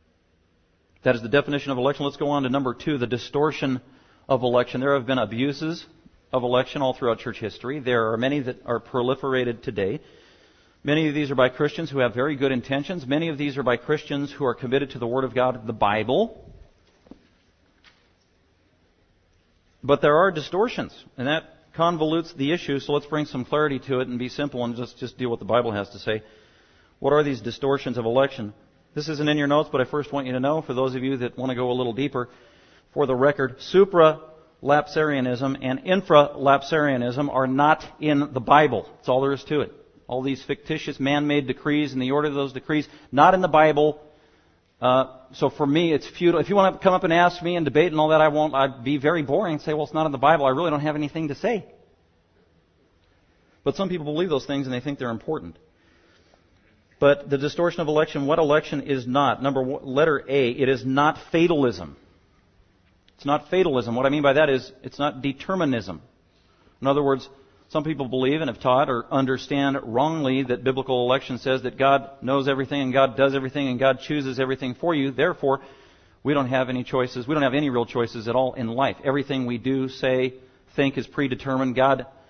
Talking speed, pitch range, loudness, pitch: 210 wpm, 125-150 Hz, -23 LUFS, 135 Hz